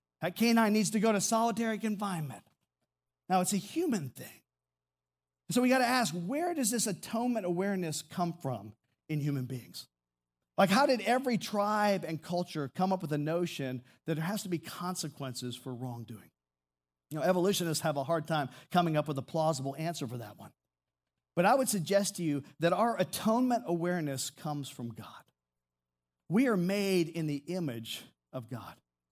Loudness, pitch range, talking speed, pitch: -32 LUFS, 125-200 Hz, 175 wpm, 160 Hz